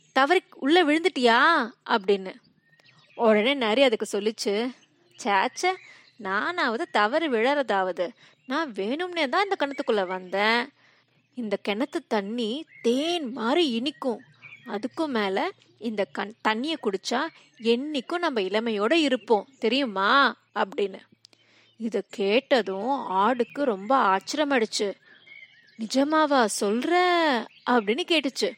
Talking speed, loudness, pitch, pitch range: 95 wpm, -25 LUFS, 245 Hz, 215-295 Hz